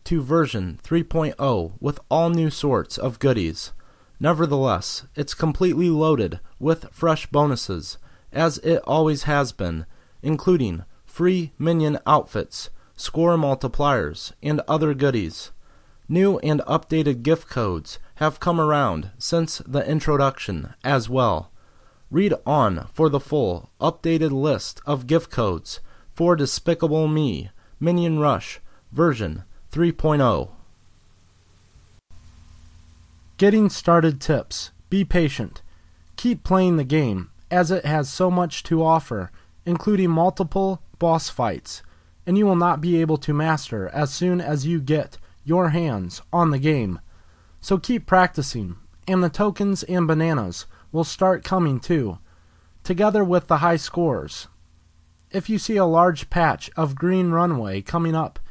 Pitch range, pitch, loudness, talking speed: 100-170 Hz, 150 Hz, -22 LUFS, 130 wpm